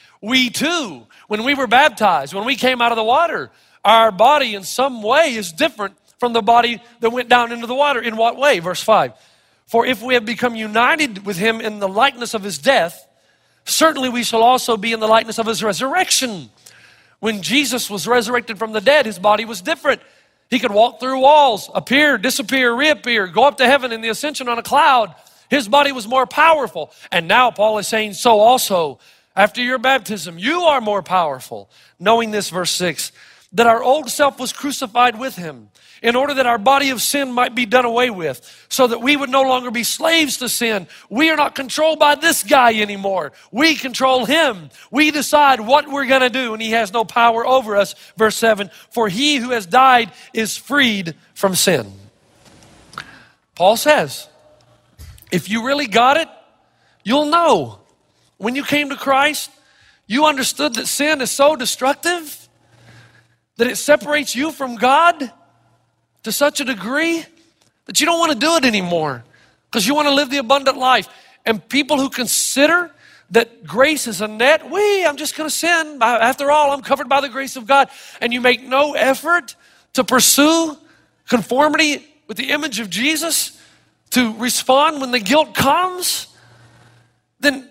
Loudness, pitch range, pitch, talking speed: -16 LUFS, 220-285 Hz, 250 Hz, 185 wpm